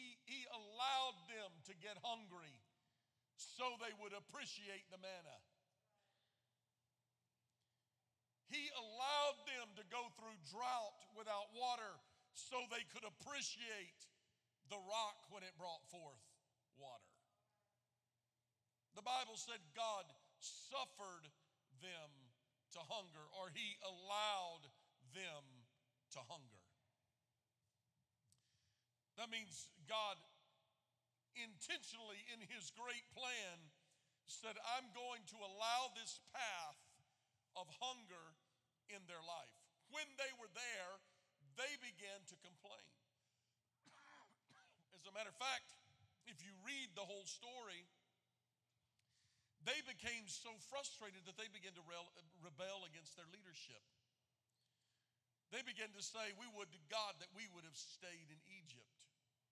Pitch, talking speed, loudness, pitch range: 190 Hz, 115 wpm, -50 LUFS, 140-230 Hz